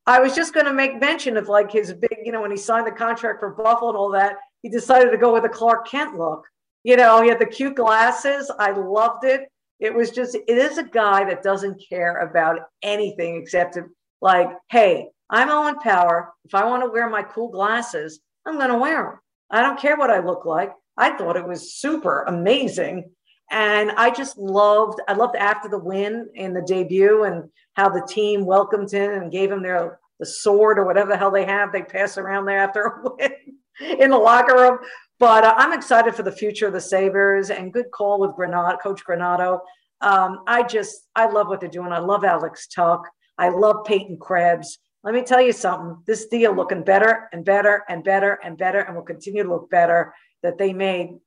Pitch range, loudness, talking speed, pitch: 185-230 Hz, -19 LUFS, 215 wpm, 205 Hz